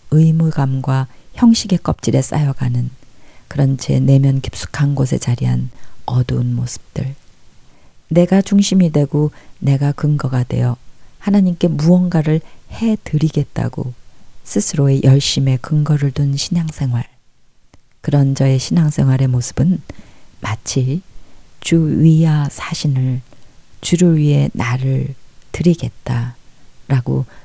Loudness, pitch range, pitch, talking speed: -16 LUFS, 130-160 Hz, 140 Hz, 235 characters per minute